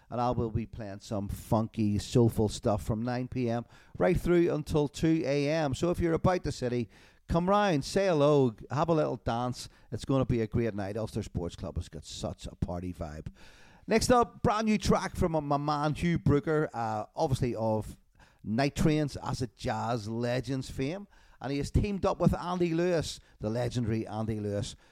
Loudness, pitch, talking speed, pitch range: -30 LUFS, 125 Hz, 190 wpm, 110-155 Hz